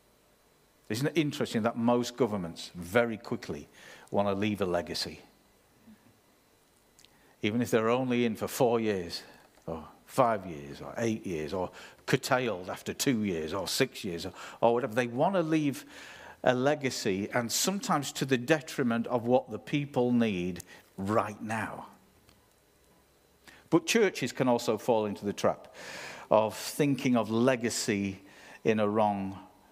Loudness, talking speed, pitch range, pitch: -30 LUFS, 145 wpm, 105-130 Hz, 115 Hz